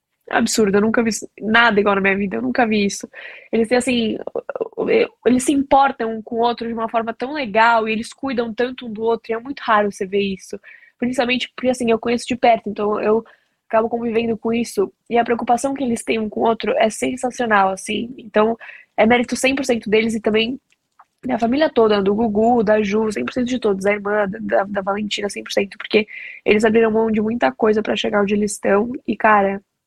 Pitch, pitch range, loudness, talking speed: 230 Hz, 215-245 Hz, -19 LUFS, 210 wpm